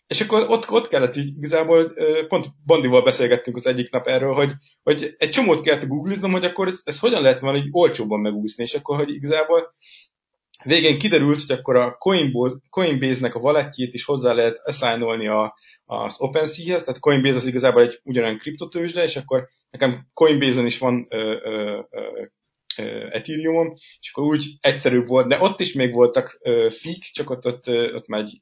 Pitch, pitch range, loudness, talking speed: 140 Hz, 125-165 Hz, -20 LUFS, 170 wpm